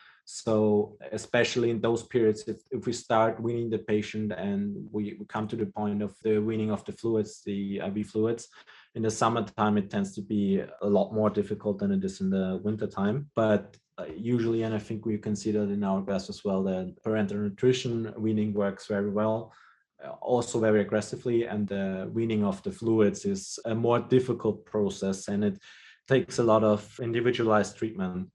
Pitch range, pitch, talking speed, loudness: 105-115 Hz, 110 Hz, 185 wpm, -28 LUFS